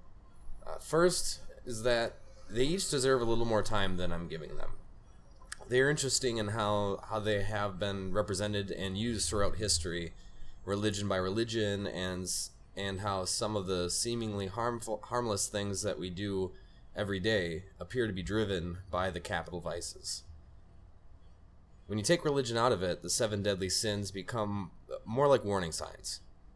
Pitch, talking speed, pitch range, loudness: 100 Hz, 160 wpm, 90-110 Hz, -33 LUFS